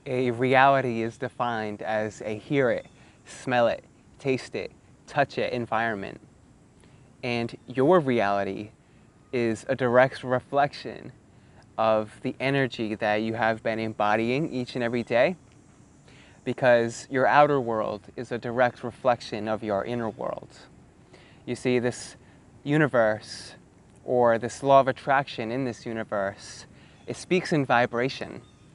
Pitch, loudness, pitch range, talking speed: 120 Hz, -26 LUFS, 110-130 Hz, 130 wpm